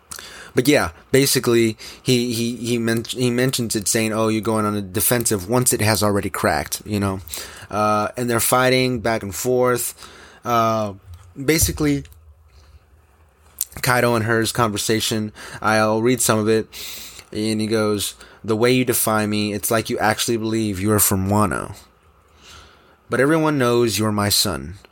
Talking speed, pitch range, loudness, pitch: 155 wpm, 100-120 Hz, -19 LUFS, 110 Hz